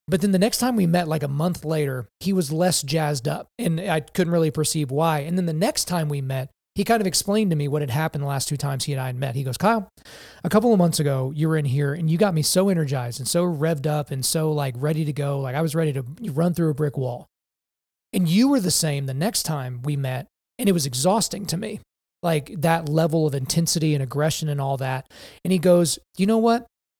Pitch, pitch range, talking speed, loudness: 160 Hz, 145-180 Hz, 260 wpm, -23 LUFS